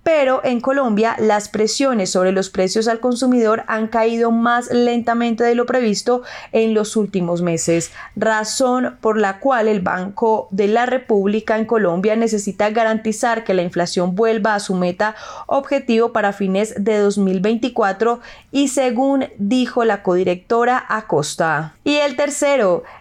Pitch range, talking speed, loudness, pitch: 200-245 Hz, 145 wpm, -17 LUFS, 220 Hz